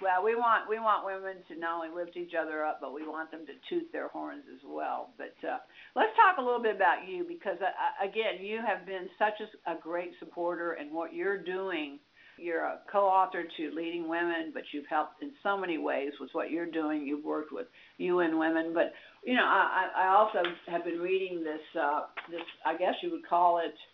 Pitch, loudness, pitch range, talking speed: 175 Hz, -31 LUFS, 165-210 Hz, 220 wpm